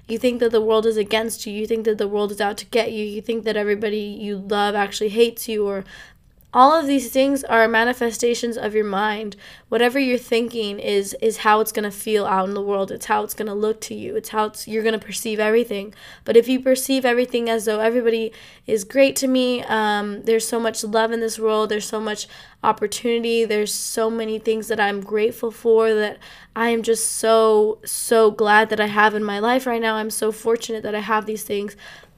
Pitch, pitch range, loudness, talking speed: 220 Hz, 210-230 Hz, -20 LUFS, 225 wpm